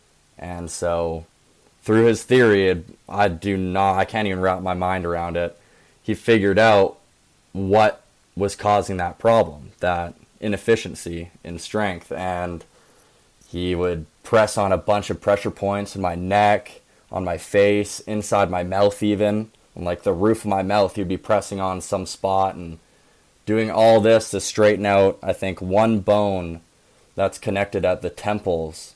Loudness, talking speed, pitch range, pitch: -21 LUFS, 160 wpm, 90-105 Hz, 100 Hz